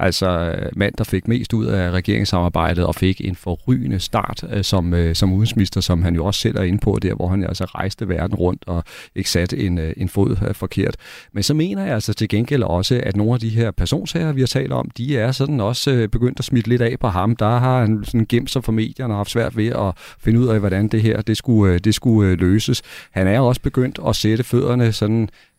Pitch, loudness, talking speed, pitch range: 110 Hz, -19 LUFS, 230 wpm, 95-120 Hz